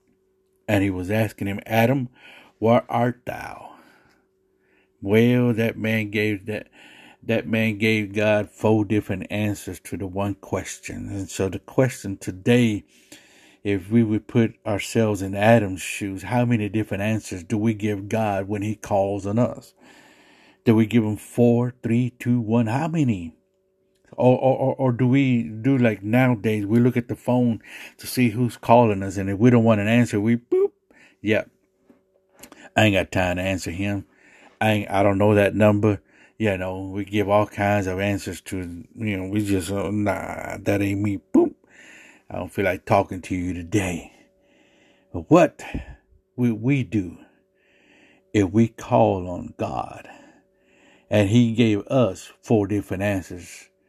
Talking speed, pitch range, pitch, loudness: 165 wpm, 100-120 Hz, 105 Hz, -22 LUFS